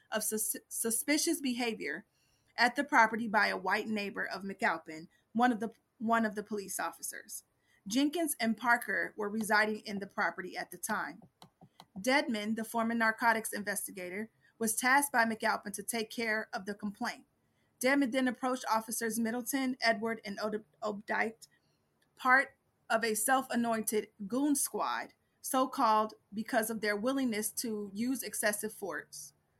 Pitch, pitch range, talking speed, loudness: 225 Hz, 215-245 Hz, 140 wpm, -33 LUFS